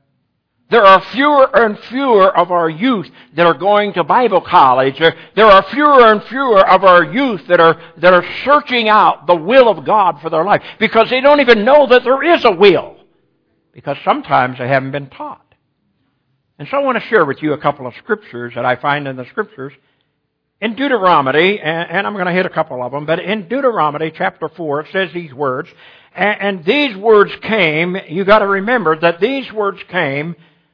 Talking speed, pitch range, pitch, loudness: 195 wpm, 155-220 Hz, 185 Hz, -12 LUFS